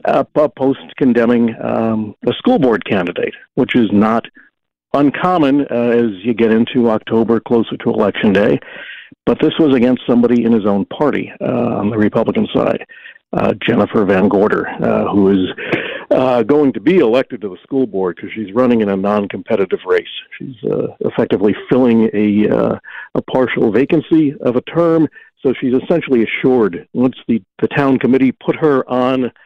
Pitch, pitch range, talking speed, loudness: 120 Hz, 110-140 Hz, 175 wpm, -15 LUFS